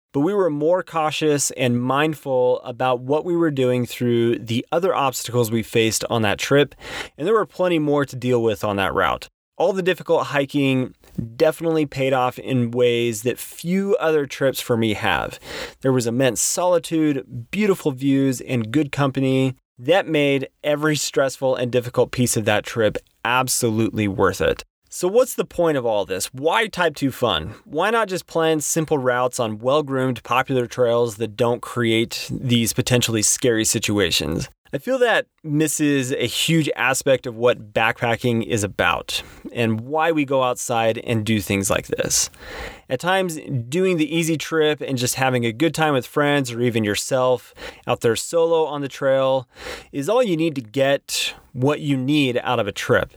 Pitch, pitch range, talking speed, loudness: 130 Hz, 120-155 Hz, 175 wpm, -20 LUFS